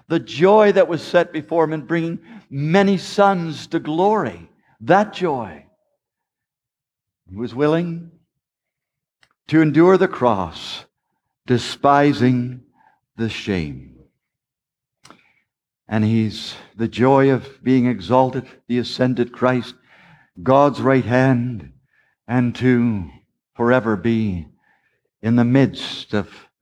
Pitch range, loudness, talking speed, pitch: 120-160 Hz, -18 LUFS, 105 wpm, 130 Hz